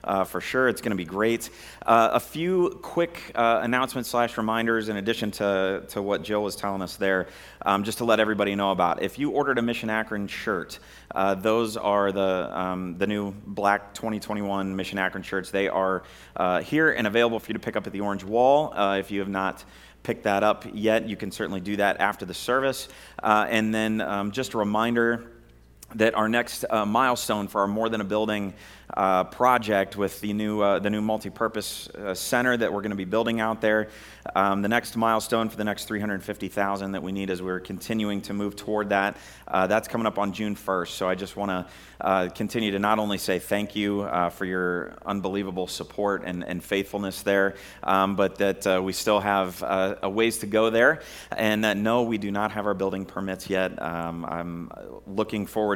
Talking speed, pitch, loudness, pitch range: 210 wpm, 100 Hz, -26 LUFS, 95-110 Hz